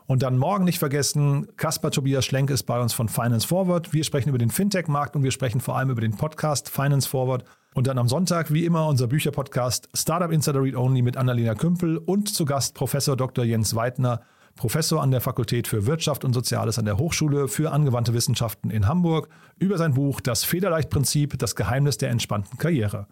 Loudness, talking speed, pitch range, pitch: -23 LUFS, 200 wpm, 125-155 Hz, 135 Hz